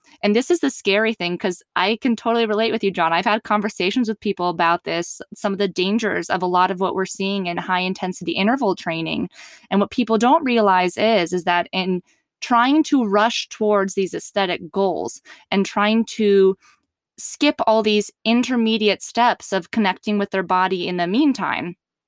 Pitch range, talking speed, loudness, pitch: 185-230 Hz, 190 wpm, -20 LUFS, 205 Hz